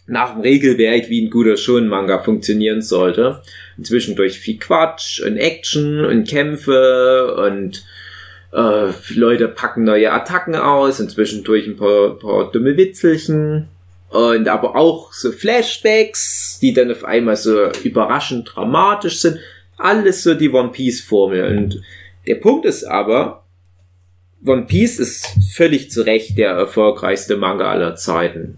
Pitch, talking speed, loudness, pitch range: 115 Hz, 130 wpm, -15 LUFS, 100-150 Hz